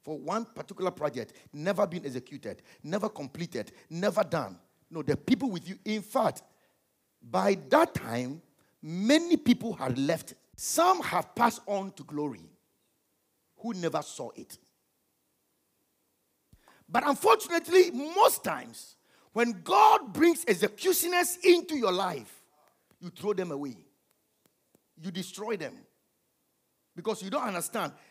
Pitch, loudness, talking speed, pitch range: 205 Hz, -28 LUFS, 120 wpm, 165-265 Hz